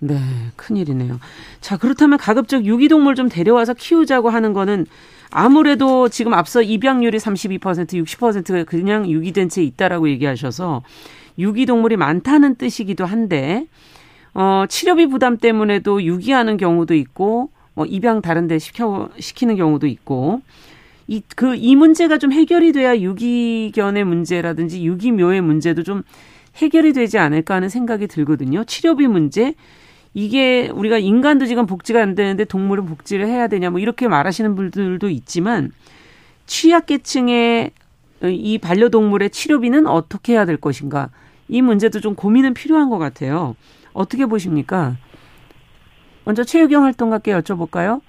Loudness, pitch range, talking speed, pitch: -16 LUFS, 175-245 Hz, 325 characters per minute, 210 Hz